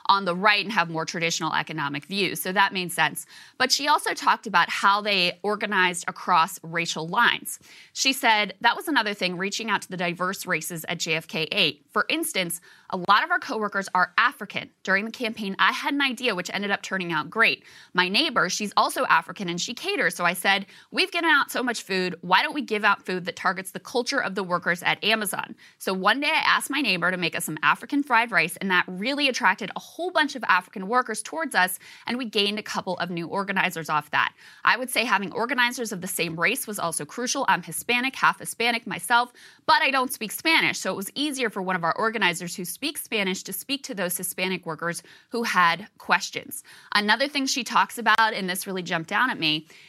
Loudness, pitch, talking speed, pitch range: -24 LUFS, 200 Hz, 225 wpm, 180-240 Hz